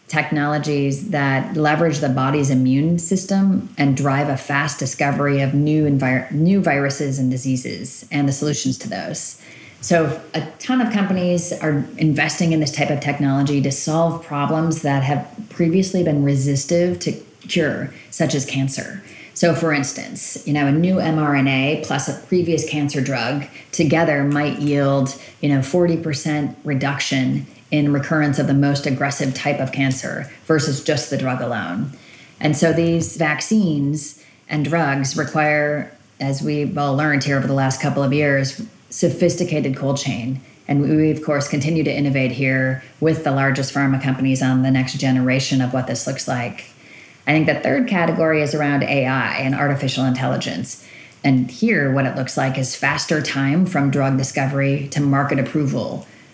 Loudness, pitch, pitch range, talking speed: -19 LUFS, 145 Hz, 135-155 Hz, 160 wpm